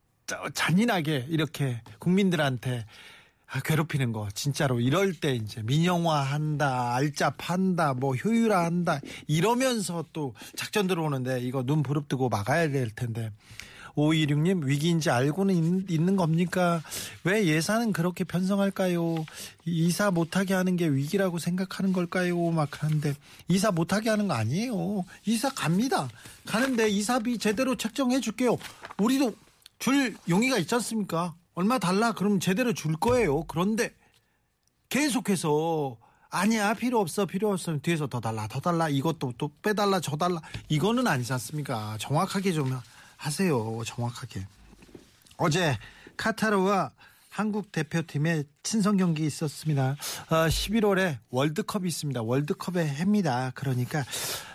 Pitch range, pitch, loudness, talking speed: 140-195 Hz, 165 Hz, -27 LUFS, 300 characters per minute